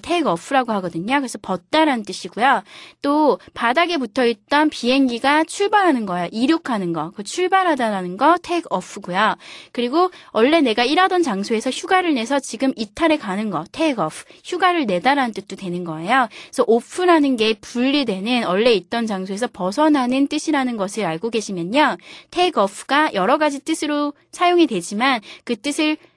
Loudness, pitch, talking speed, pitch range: -19 LUFS, 265 Hz, 395 characters per minute, 215-315 Hz